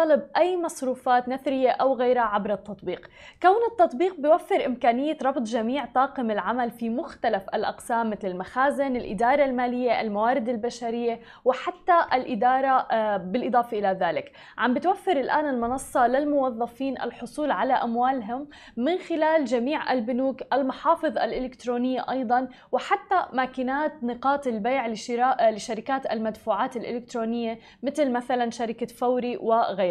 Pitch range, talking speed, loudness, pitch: 235-280 Hz, 115 wpm, -25 LUFS, 255 Hz